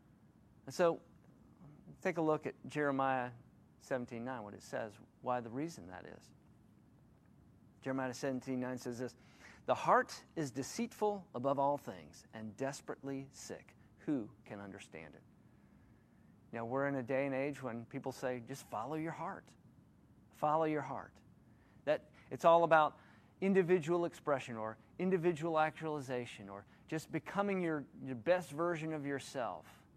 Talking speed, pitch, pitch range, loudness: 140 wpm, 135 Hz, 125-160 Hz, -38 LUFS